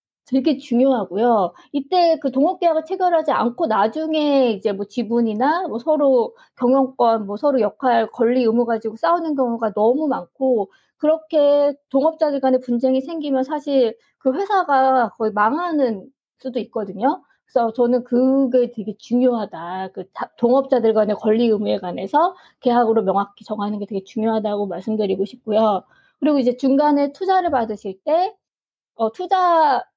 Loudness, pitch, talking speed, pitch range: -19 LUFS, 255 Hz, 325 characters per minute, 220-290 Hz